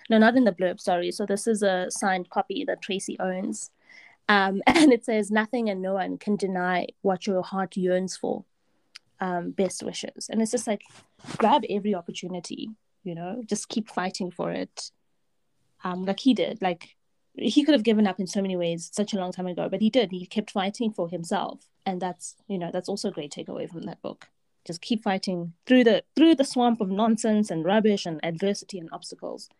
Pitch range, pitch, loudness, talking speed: 180-220 Hz, 195 Hz, -26 LUFS, 205 wpm